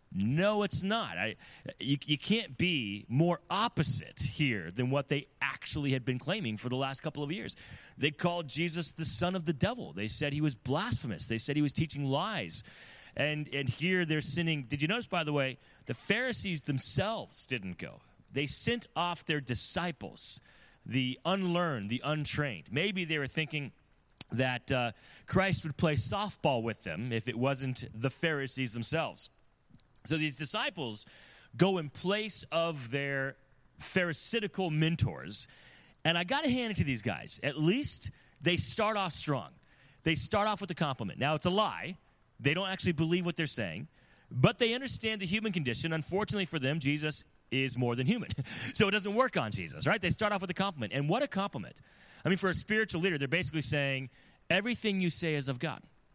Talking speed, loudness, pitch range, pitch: 185 wpm, -32 LUFS, 135-180 Hz, 150 Hz